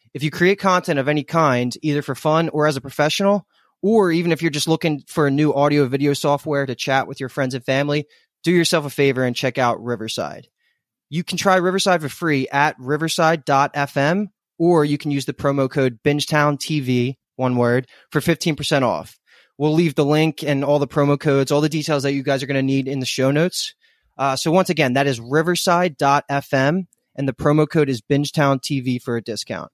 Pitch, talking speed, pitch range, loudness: 145 Hz, 205 wpm, 135-160 Hz, -19 LUFS